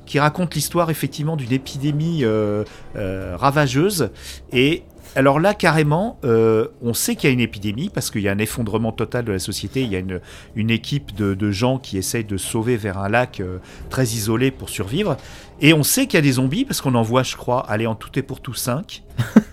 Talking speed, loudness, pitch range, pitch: 225 wpm, -20 LUFS, 105-145 Hz, 125 Hz